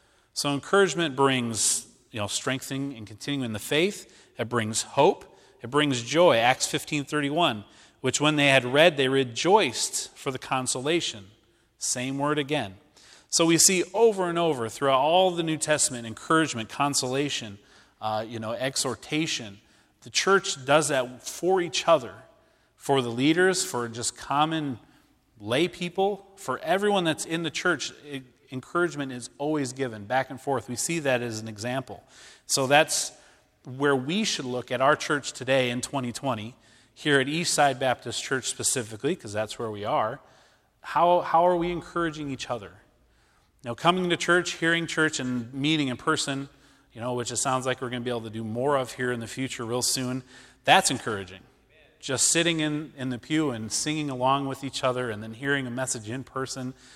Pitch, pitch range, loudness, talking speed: 135 Hz, 120-155 Hz, -25 LUFS, 175 wpm